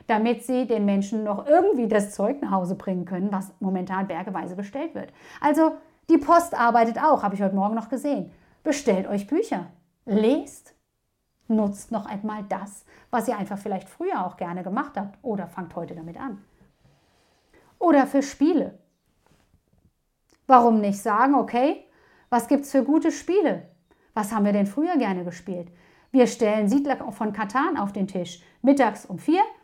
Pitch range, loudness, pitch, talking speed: 195-275 Hz, -24 LUFS, 220 Hz, 165 wpm